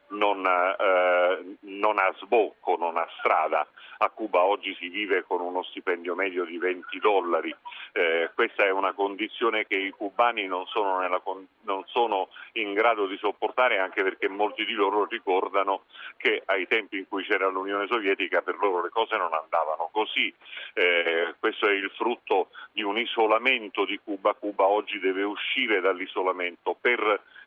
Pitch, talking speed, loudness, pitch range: 95 Hz, 160 wpm, -26 LUFS, 95-110 Hz